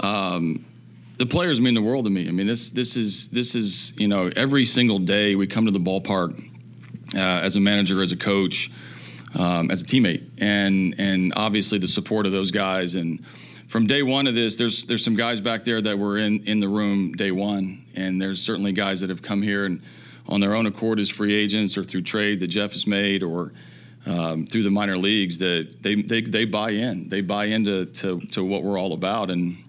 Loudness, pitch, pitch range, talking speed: -22 LUFS, 100 Hz, 95-110 Hz, 220 wpm